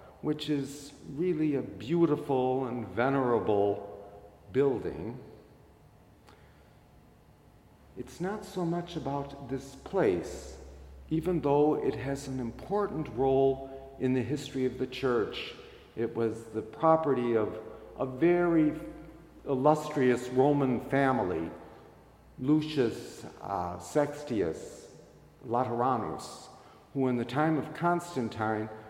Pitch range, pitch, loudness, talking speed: 120-150 Hz, 135 Hz, -30 LUFS, 100 wpm